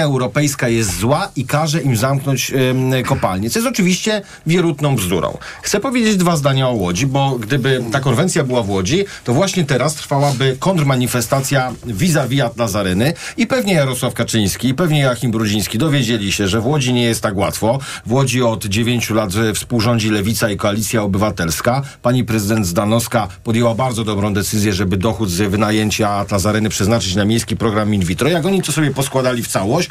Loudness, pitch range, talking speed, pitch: -16 LUFS, 110-140 Hz, 175 wpm, 120 Hz